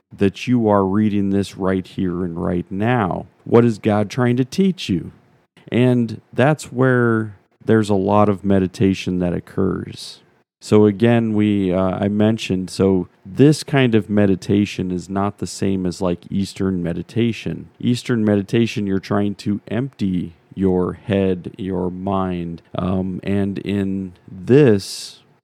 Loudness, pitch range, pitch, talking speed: -19 LUFS, 95-115 Hz, 100 Hz, 140 wpm